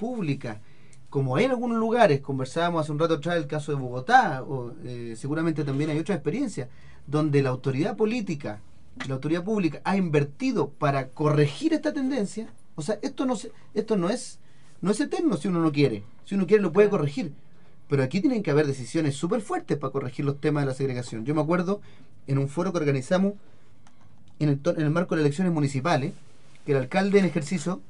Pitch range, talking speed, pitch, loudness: 135-185 Hz, 200 wpm, 150 Hz, -26 LUFS